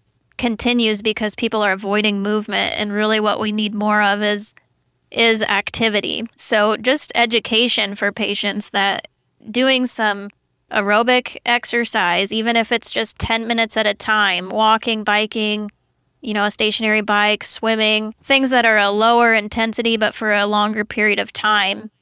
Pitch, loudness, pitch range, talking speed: 215 Hz, -17 LUFS, 210-230 Hz, 155 wpm